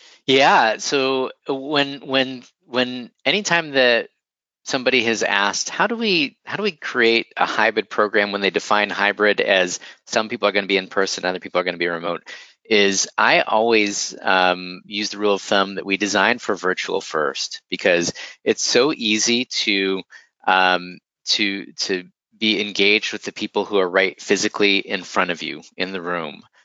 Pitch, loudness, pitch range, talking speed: 105 Hz, -19 LUFS, 95-130 Hz, 180 wpm